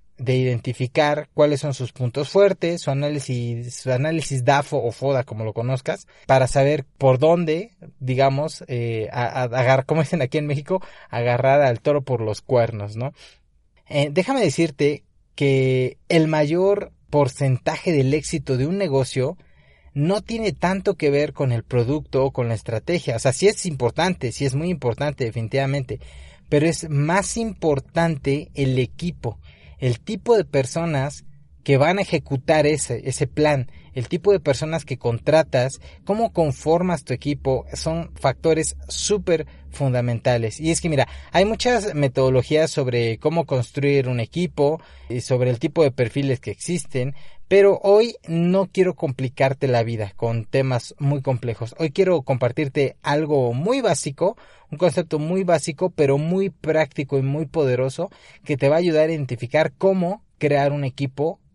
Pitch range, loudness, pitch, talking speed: 125-165 Hz, -21 LUFS, 145 Hz, 155 wpm